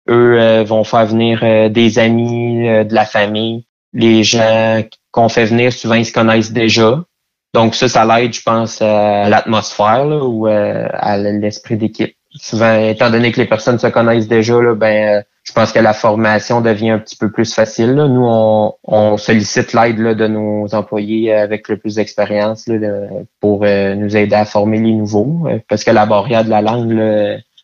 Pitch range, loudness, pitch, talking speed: 105-115 Hz, -12 LUFS, 110 Hz, 200 wpm